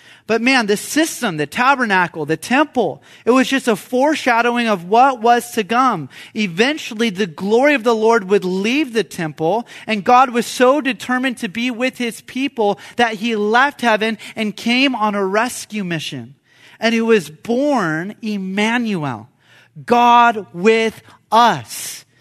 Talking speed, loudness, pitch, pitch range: 150 wpm, -16 LUFS, 225 Hz, 205-245 Hz